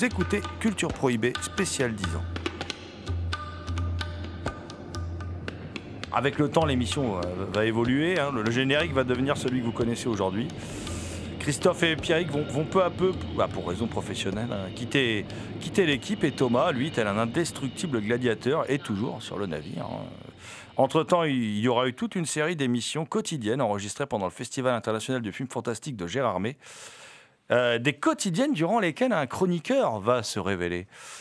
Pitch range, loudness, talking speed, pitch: 105-150 Hz, -27 LUFS, 160 wpm, 125 Hz